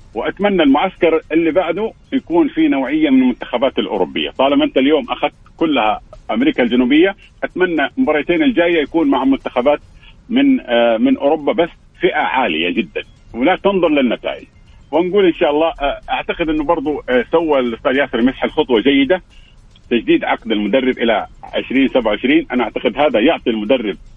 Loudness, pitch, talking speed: -16 LUFS, 195 Hz, 140 wpm